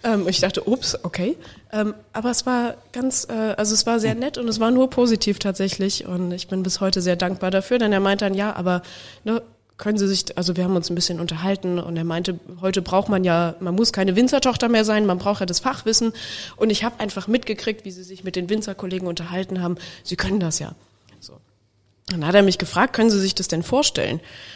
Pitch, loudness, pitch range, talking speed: 195 Hz, -21 LUFS, 180-220 Hz, 220 wpm